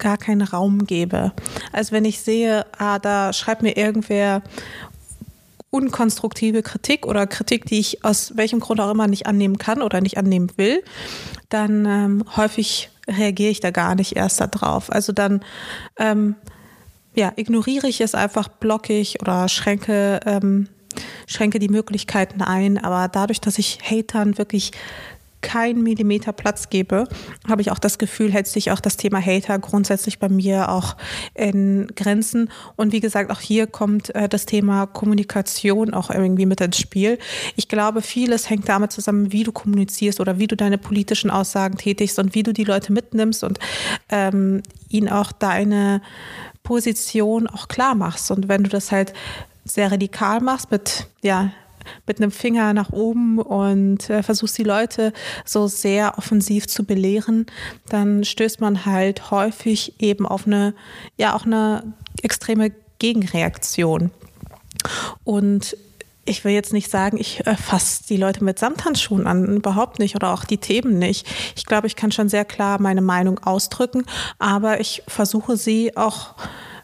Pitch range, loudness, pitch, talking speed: 200-220 Hz, -20 LUFS, 210 Hz, 160 wpm